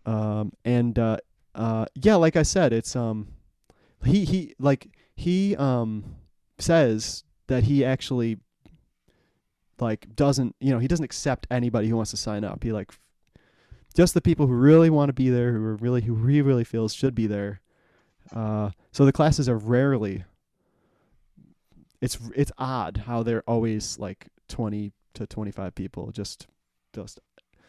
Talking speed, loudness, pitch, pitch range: 160 wpm, -24 LUFS, 115 Hz, 105-135 Hz